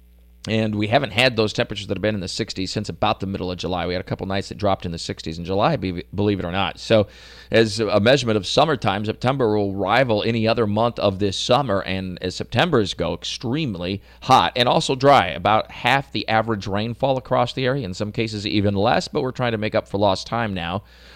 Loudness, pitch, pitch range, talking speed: -21 LUFS, 105 Hz, 95-115 Hz, 230 wpm